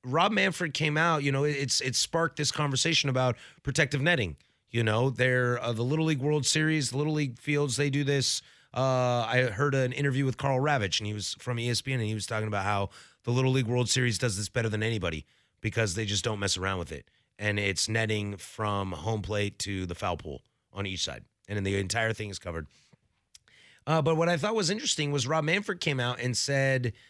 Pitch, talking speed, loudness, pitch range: 125 Hz, 225 wpm, -28 LUFS, 105-145 Hz